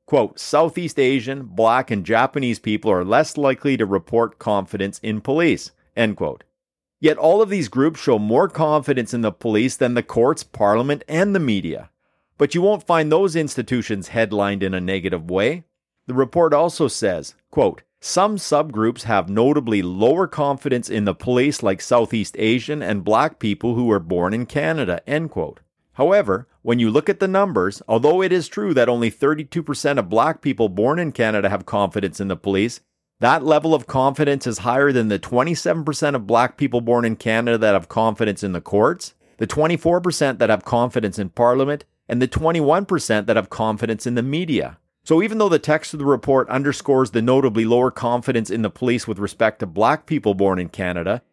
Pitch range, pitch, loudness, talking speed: 110-150 Hz, 125 Hz, -19 LUFS, 185 wpm